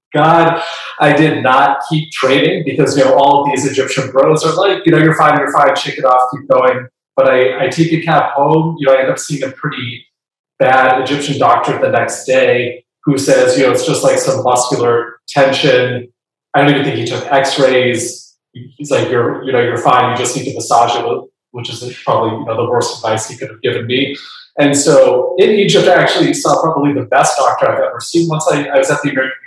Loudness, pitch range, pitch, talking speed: -12 LUFS, 130-155 Hz, 140 Hz, 230 wpm